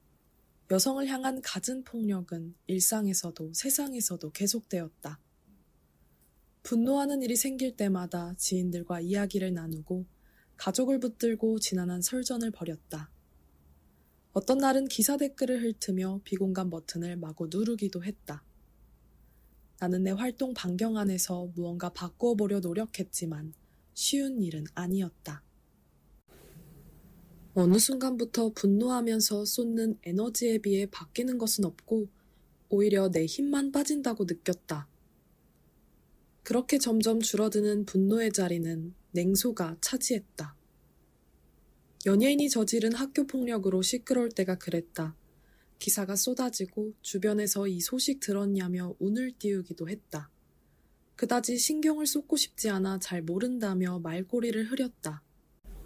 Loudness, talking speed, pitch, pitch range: -30 LUFS, 270 characters per minute, 195 Hz, 175-235 Hz